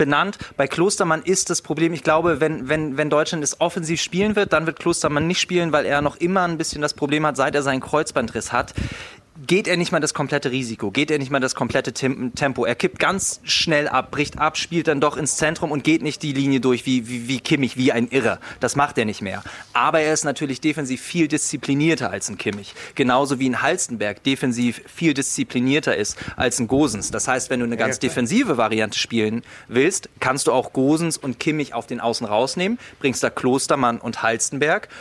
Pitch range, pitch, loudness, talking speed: 125-155 Hz, 140 Hz, -21 LUFS, 215 wpm